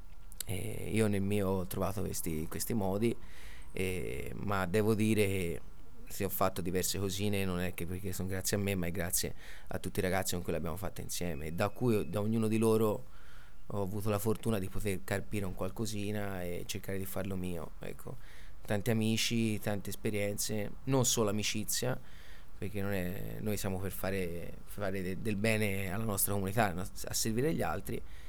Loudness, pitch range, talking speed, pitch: -35 LUFS, 95-105 Hz, 180 wpm, 100 Hz